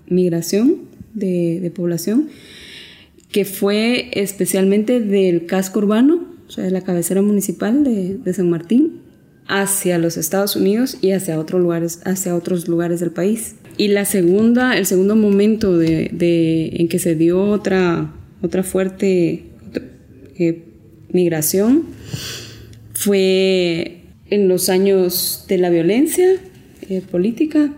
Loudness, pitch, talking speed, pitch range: -17 LUFS, 185 Hz, 130 wpm, 170-200 Hz